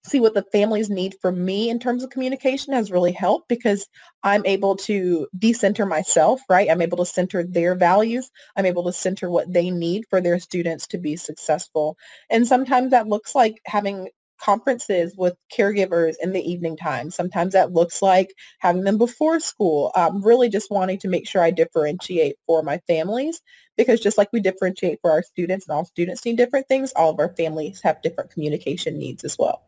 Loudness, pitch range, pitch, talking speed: -21 LUFS, 175-225 Hz, 190 Hz, 195 wpm